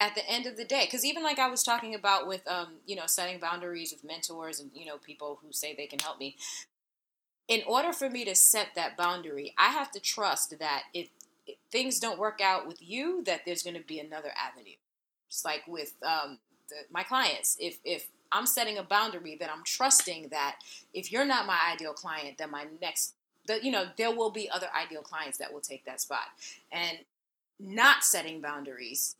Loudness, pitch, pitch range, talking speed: -30 LUFS, 175 Hz, 155-230 Hz, 210 wpm